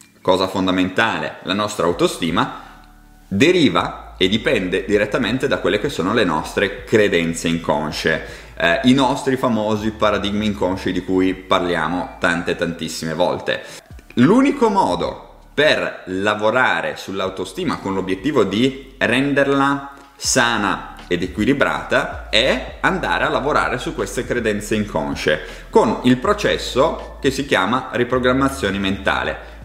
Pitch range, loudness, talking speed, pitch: 90-125 Hz, -18 LUFS, 115 wpm, 100 Hz